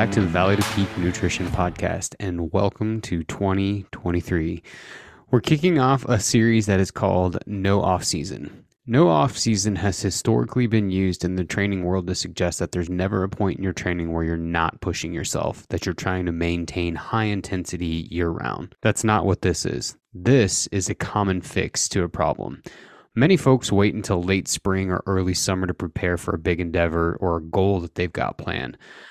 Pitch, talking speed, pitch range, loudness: 95 Hz, 190 wpm, 90-105 Hz, -23 LUFS